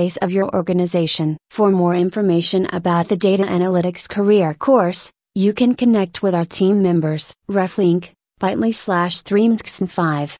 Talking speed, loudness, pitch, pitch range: 135 wpm, -17 LUFS, 185 Hz, 175-200 Hz